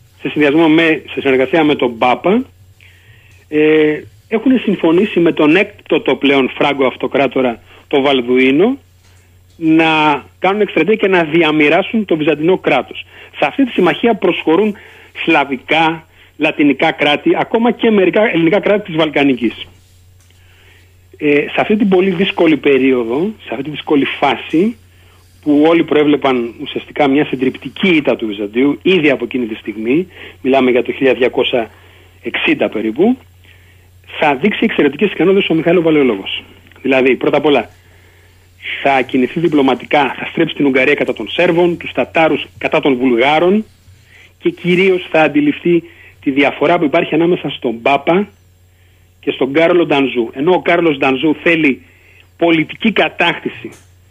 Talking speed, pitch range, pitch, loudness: 135 wpm, 105-165 Hz, 145 Hz, -13 LUFS